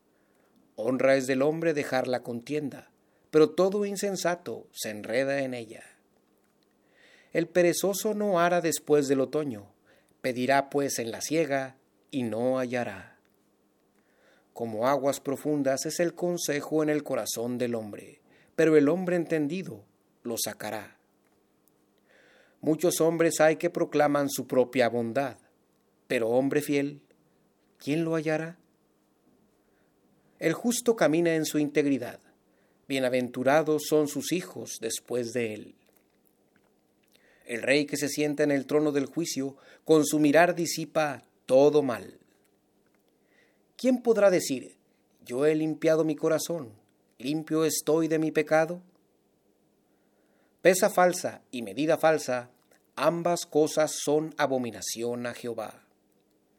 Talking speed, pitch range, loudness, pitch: 120 wpm, 125-160 Hz, -27 LUFS, 145 Hz